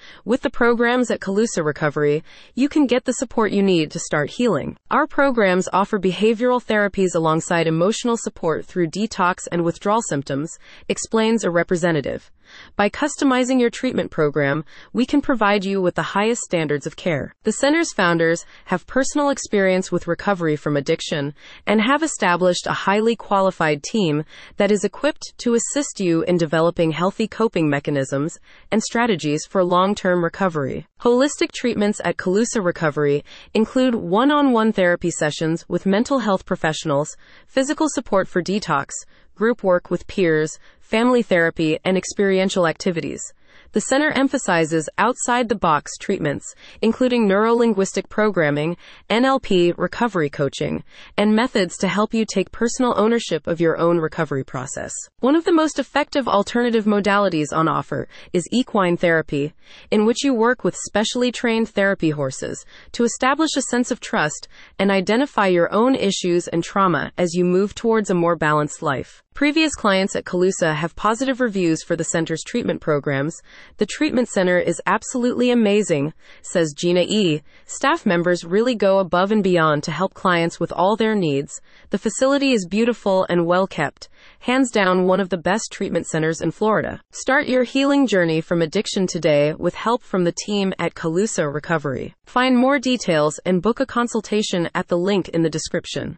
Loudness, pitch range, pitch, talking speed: -20 LUFS, 170-235 Hz, 195 Hz, 160 wpm